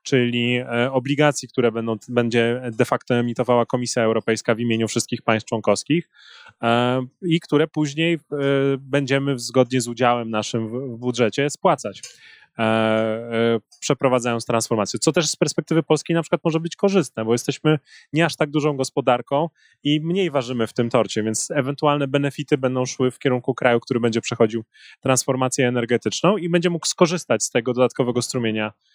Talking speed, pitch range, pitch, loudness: 150 wpm, 120-150 Hz, 125 Hz, -21 LUFS